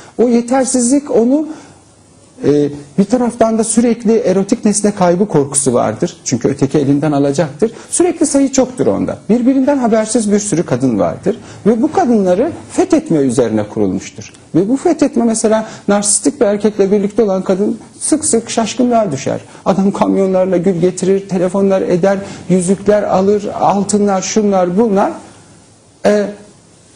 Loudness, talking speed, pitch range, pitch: -13 LUFS, 130 wpm, 180-235 Hz, 205 Hz